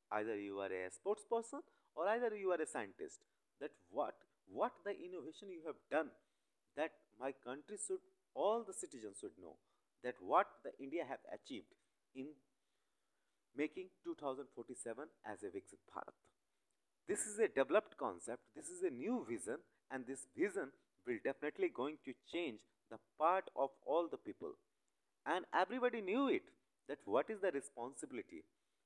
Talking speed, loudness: 155 wpm, -43 LUFS